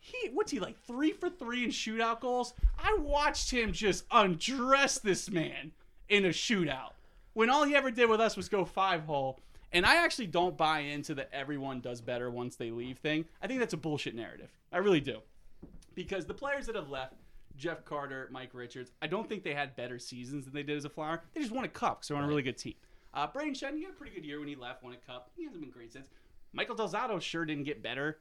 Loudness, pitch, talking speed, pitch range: -33 LUFS, 175 Hz, 245 wpm, 145-240 Hz